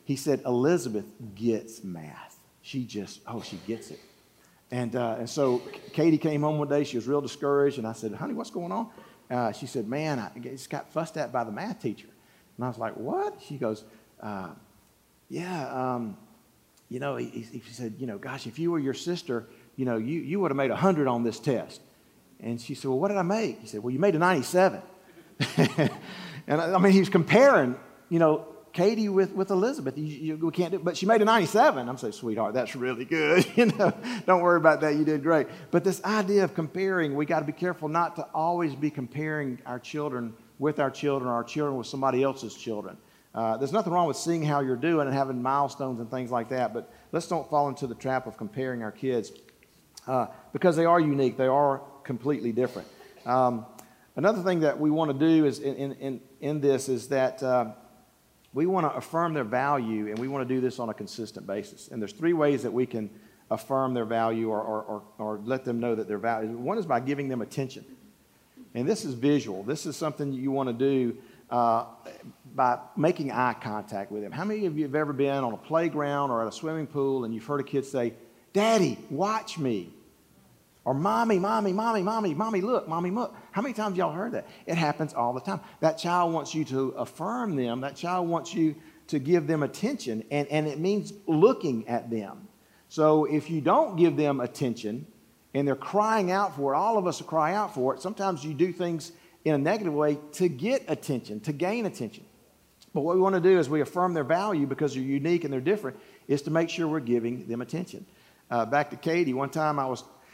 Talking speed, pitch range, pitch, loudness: 220 wpm, 125-170 Hz, 145 Hz, -27 LUFS